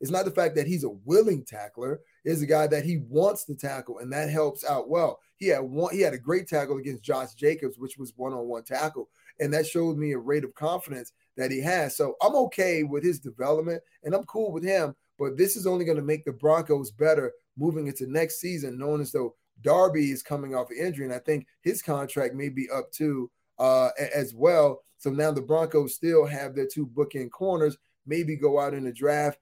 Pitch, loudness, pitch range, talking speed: 150 Hz, -27 LUFS, 135-165 Hz, 230 wpm